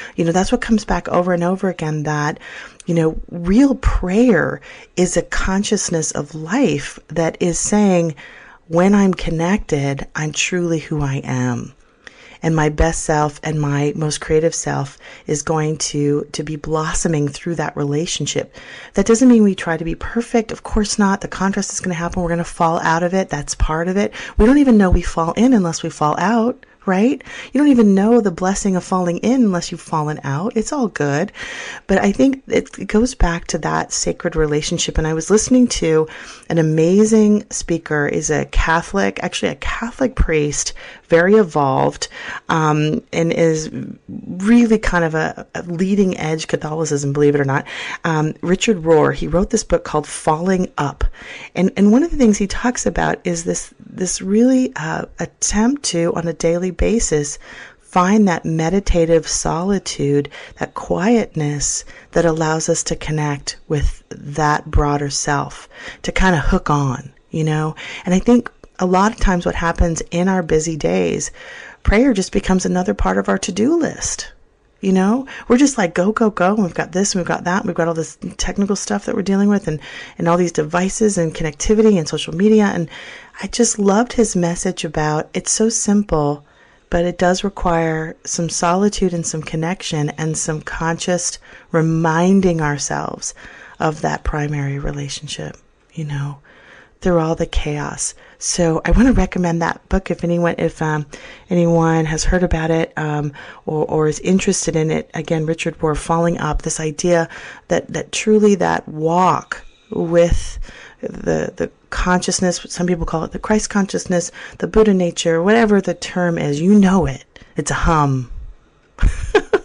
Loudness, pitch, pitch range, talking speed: -17 LUFS, 170 Hz, 155-200 Hz, 175 wpm